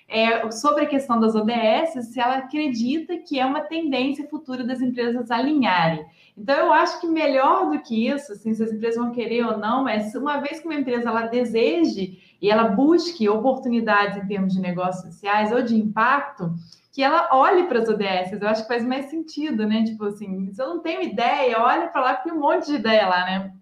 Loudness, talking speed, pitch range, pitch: -22 LUFS, 215 wpm, 215-290 Hz, 240 Hz